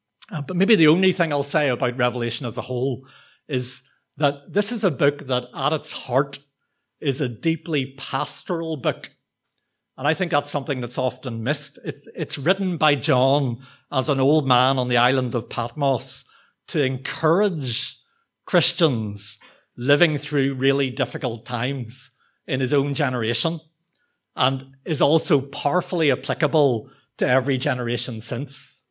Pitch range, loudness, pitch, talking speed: 130-155 Hz, -22 LUFS, 140 Hz, 145 wpm